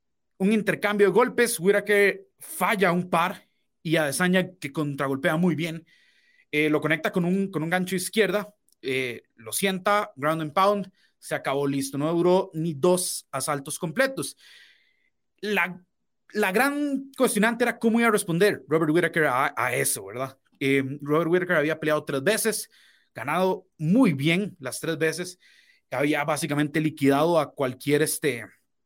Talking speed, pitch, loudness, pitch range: 150 wpm, 175 Hz, -24 LUFS, 150-205 Hz